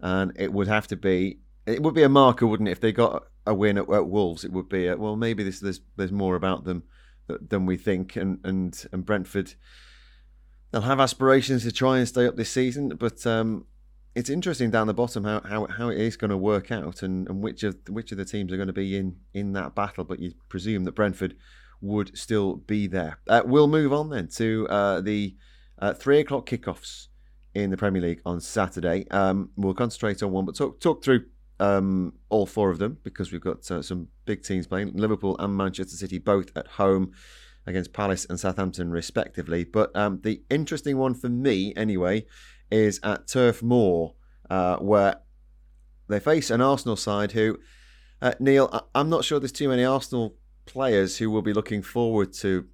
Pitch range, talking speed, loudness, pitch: 95-115 Hz, 205 wpm, -25 LUFS, 100 Hz